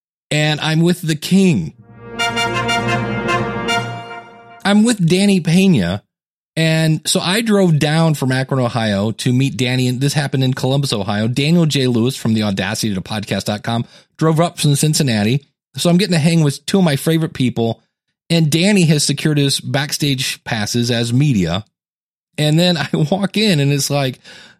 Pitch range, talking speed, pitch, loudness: 115-165 Hz, 160 wpm, 140 Hz, -16 LUFS